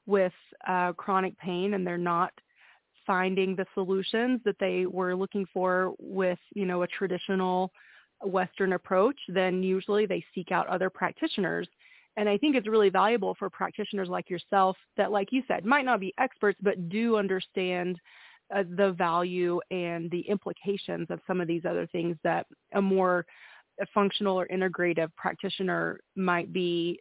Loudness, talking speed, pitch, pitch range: -29 LUFS, 160 wpm, 190 Hz, 180-200 Hz